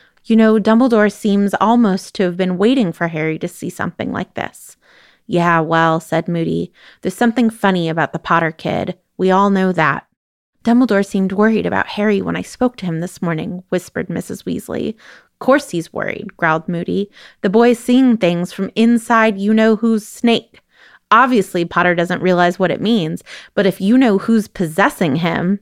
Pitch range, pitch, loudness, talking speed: 175-220 Hz, 195 Hz, -16 LUFS, 180 wpm